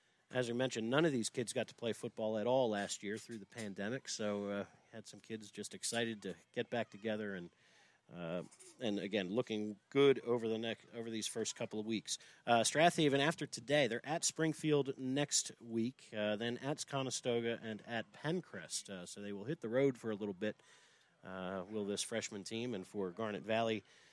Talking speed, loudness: 200 wpm, -38 LUFS